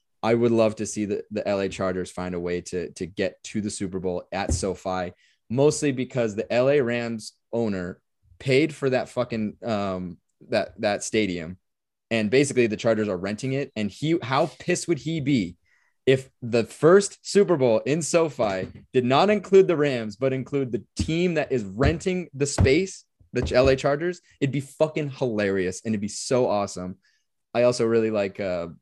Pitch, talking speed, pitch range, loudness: 120 Hz, 180 wpm, 100-140 Hz, -24 LUFS